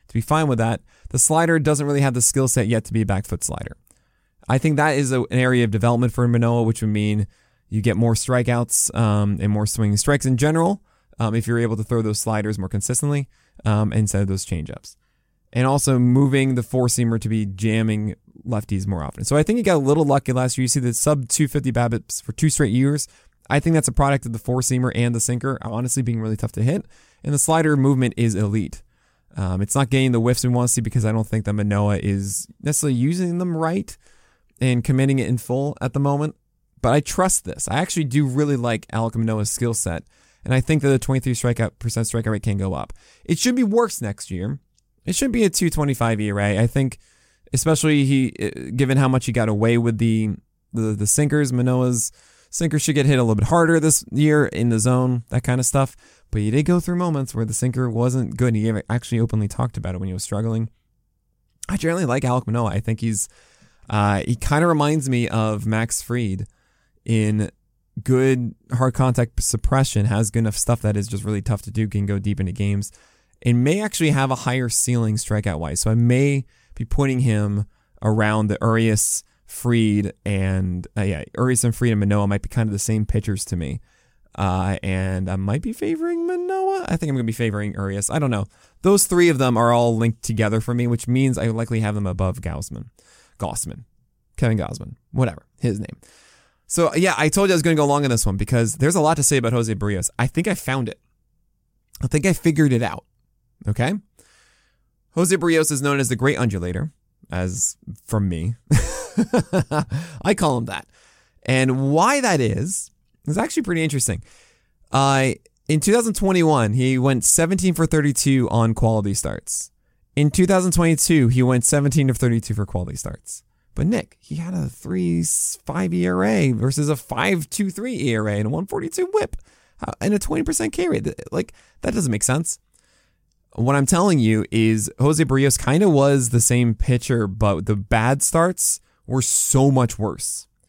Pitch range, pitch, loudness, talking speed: 110-145 Hz, 120 Hz, -20 LUFS, 205 wpm